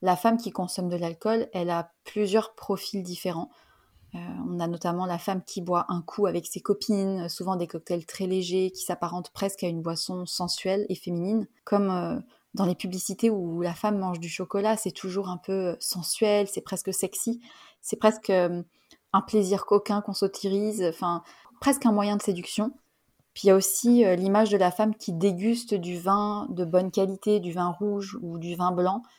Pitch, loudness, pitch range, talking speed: 190 Hz, -27 LUFS, 180-205 Hz, 195 wpm